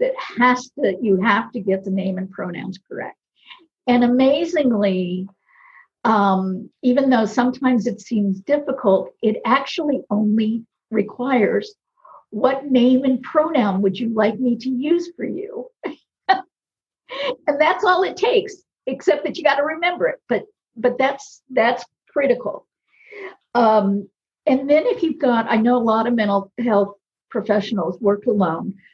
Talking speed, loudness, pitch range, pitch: 145 wpm, -19 LUFS, 210-305 Hz, 250 Hz